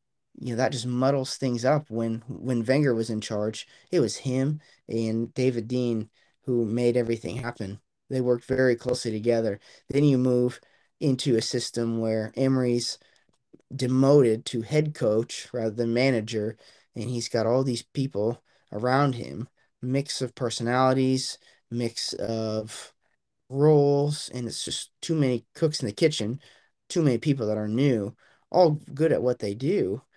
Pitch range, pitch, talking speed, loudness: 115-135 Hz, 125 Hz, 155 wpm, -26 LUFS